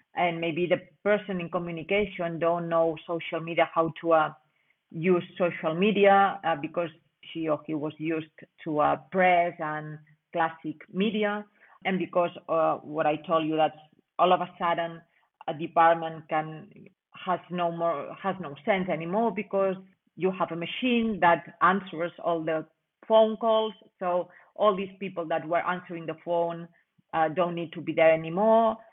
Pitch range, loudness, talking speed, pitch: 160-190 Hz, -27 LUFS, 160 wpm, 170 Hz